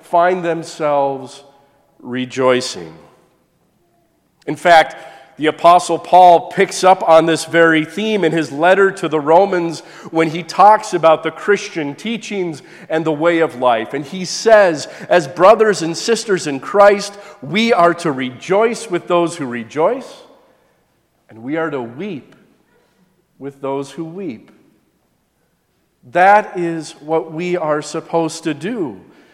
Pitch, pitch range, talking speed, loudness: 165 Hz, 155-185 Hz, 135 wpm, -15 LUFS